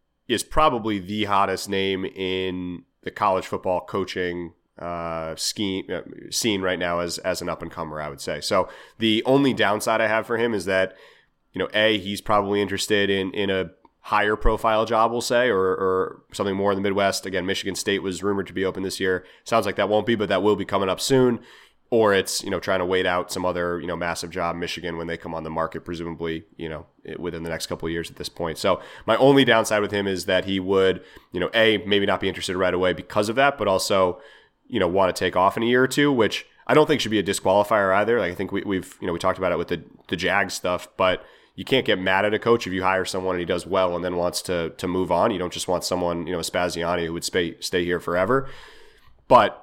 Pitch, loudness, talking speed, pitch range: 95 Hz, -23 LUFS, 255 wpm, 90-105 Hz